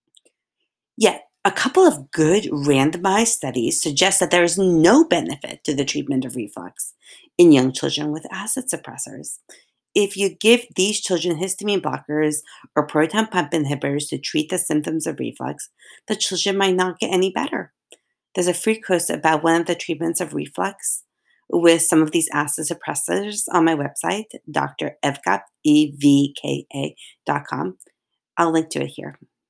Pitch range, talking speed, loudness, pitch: 150-195 Hz, 155 wpm, -20 LUFS, 170 Hz